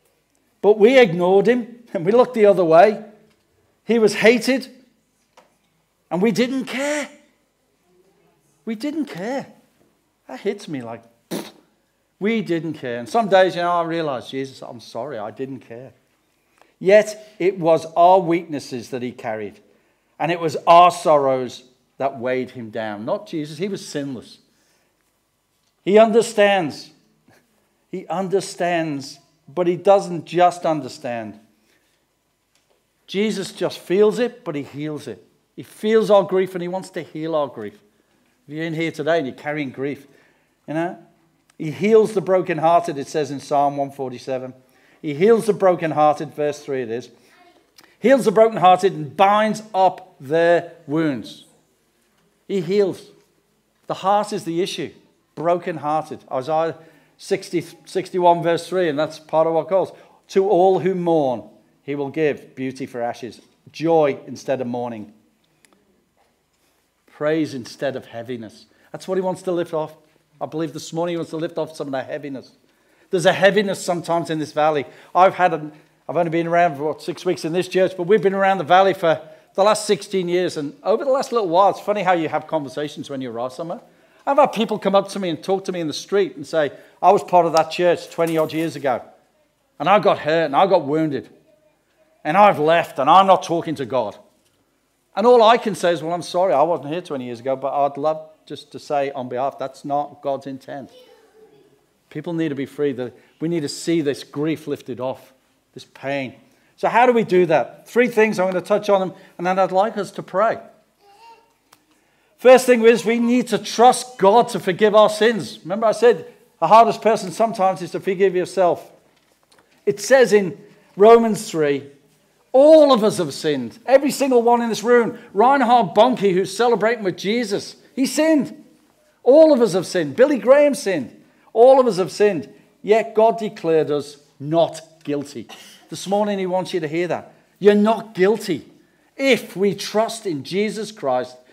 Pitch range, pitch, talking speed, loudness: 150-210 Hz, 175 Hz, 180 wpm, -19 LUFS